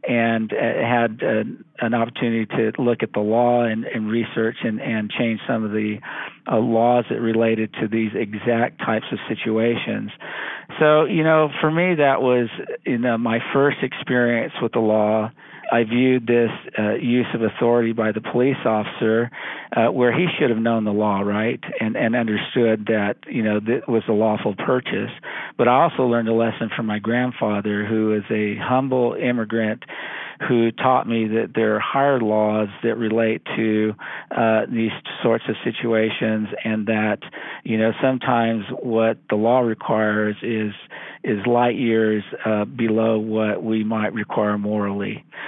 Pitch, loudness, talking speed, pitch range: 115 Hz, -21 LUFS, 160 wpm, 110-120 Hz